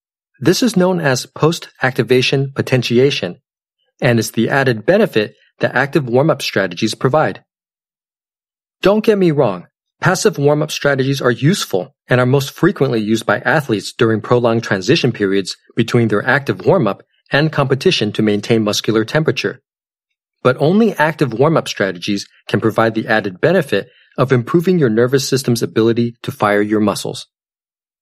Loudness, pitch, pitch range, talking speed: -15 LUFS, 125 Hz, 110-145 Hz, 140 wpm